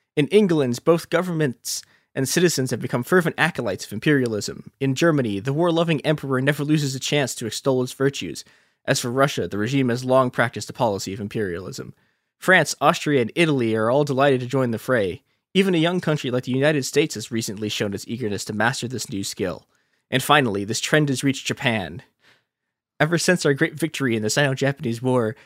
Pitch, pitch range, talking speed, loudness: 135 Hz, 120-150 Hz, 200 wpm, -22 LUFS